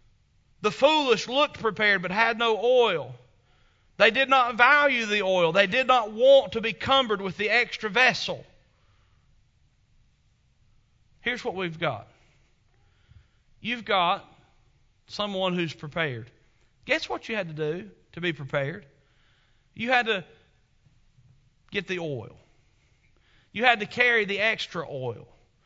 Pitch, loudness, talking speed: 185 Hz, -24 LUFS, 130 wpm